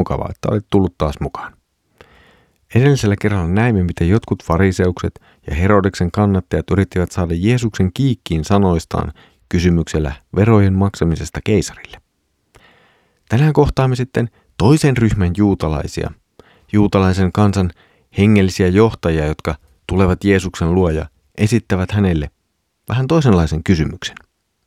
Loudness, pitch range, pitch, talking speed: -16 LUFS, 85-105 Hz, 95 Hz, 105 wpm